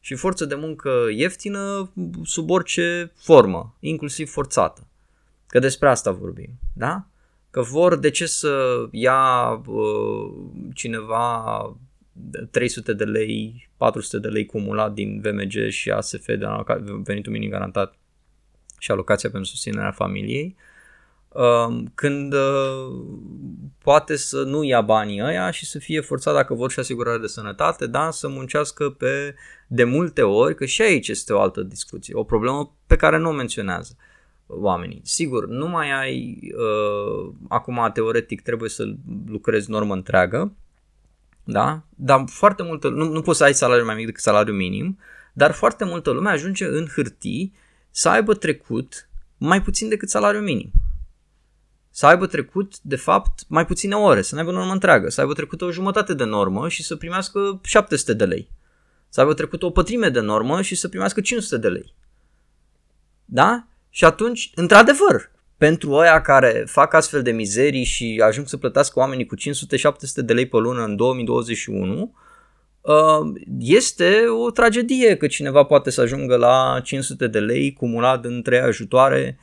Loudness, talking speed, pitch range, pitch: -20 LUFS, 155 wpm, 115-175 Hz, 140 Hz